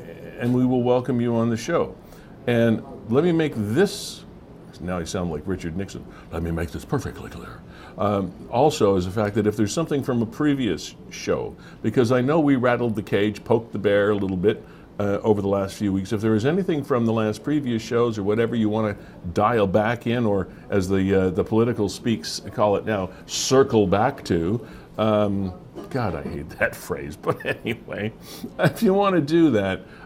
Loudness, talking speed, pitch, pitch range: -23 LUFS, 200 wpm, 110 Hz, 100-120 Hz